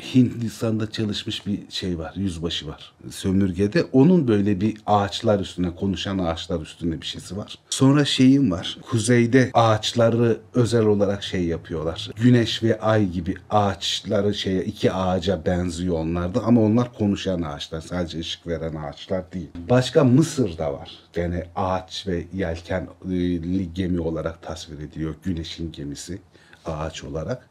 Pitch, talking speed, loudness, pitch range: 95 Hz, 135 wpm, -22 LUFS, 85-110 Hz